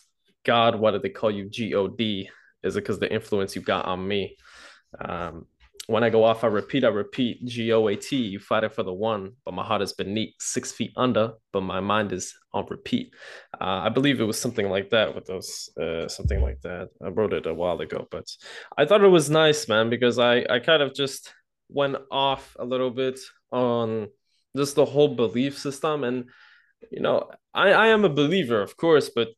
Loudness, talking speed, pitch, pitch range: -24 LUFS, 205 wpm, 115 Hz, 105-130 Hz